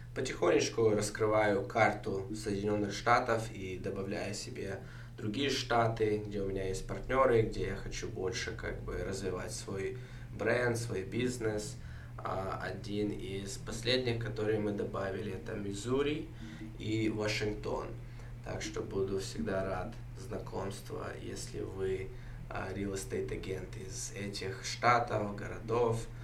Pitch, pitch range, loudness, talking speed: 110 Hz, 100-120 Hz, -35 LUFS, 115 wpm